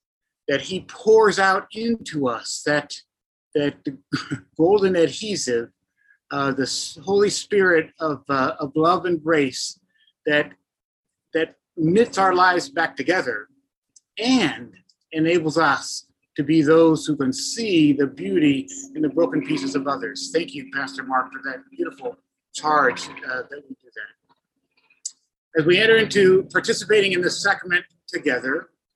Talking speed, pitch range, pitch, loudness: 135 wpm, 145-215 Hz, 170 Hz, -21 LUFS